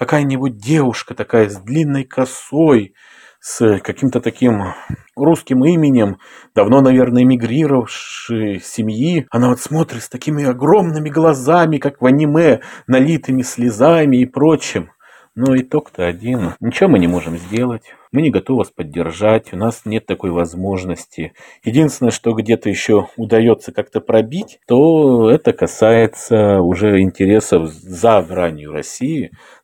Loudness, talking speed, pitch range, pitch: -15 LUFS, 125 wpm, 105-135 Hz, 120 Hz